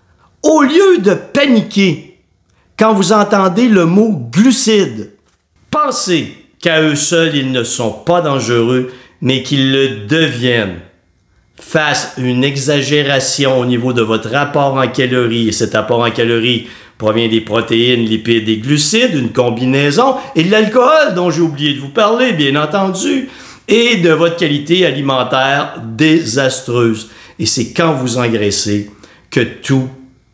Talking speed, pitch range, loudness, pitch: 140 wpm, 120-175 Hz, -12 LUFS, 140 Hz